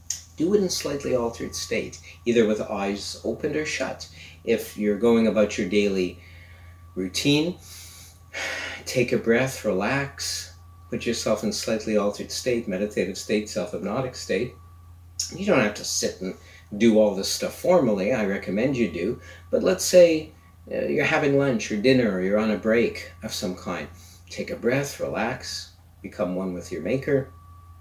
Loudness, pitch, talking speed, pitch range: -24 LUFS, 95 Hz, 160 wpm, 90-115 Hz